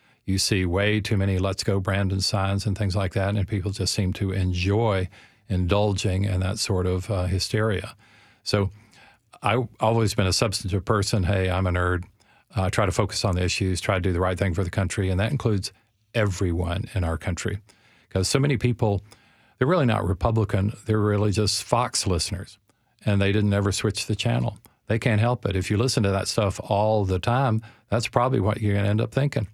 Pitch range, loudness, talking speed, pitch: 95-110 Hz, -24 LUFS, 210 wpm, 105 Hz